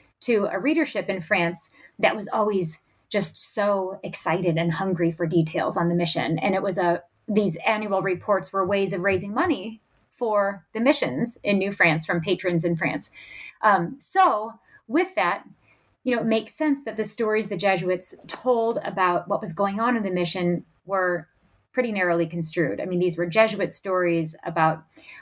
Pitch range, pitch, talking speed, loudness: 175-220 Hz, 195 Hz, 175 wpm, -24 LUFS